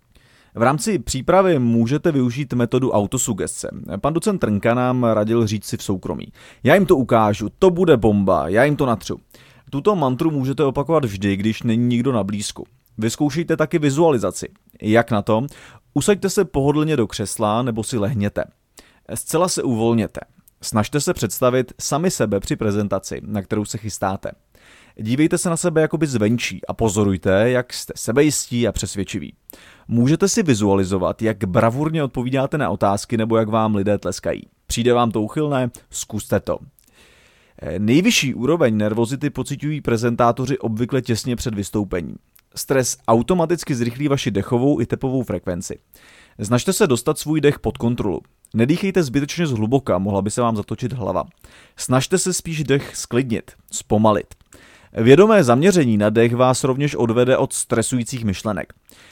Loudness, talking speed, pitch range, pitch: -19 LUFS, 150 wpm, 110-145 Hz, 120 Hz